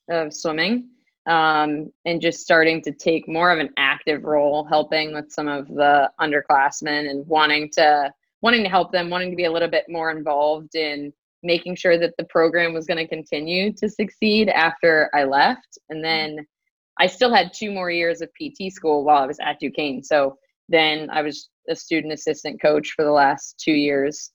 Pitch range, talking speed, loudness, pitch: 150-170 Hz, 190 wpm, -20 LUFS, 160 Hz